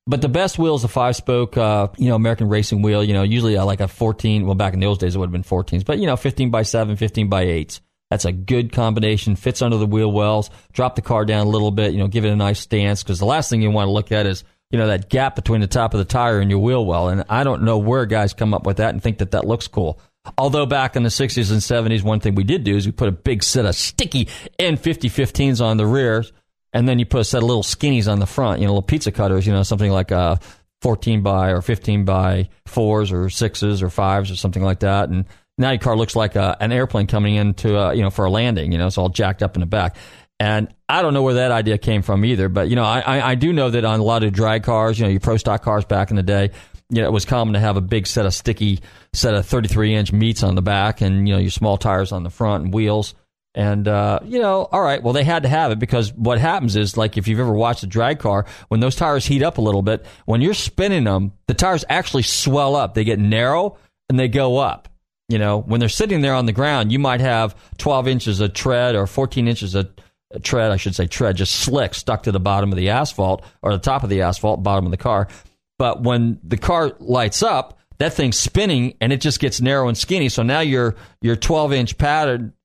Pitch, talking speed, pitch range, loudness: 110 Hz, 270 wpm, 100-125 Hz, -18 LUFS